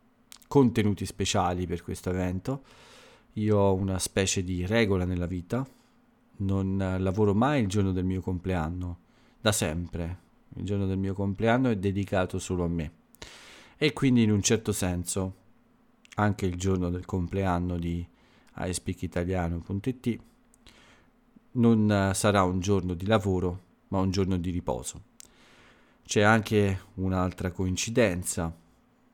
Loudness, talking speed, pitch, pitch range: -28 LUFS, 125 wpm, 95 Hz, 90-105 Hz